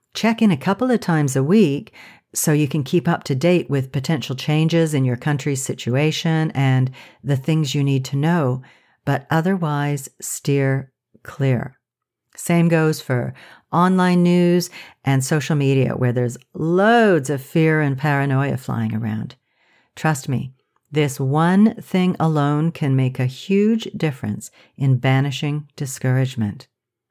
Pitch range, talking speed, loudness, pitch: 135-165 Hz, 140 wpm, -19 LUFS, 145 Hz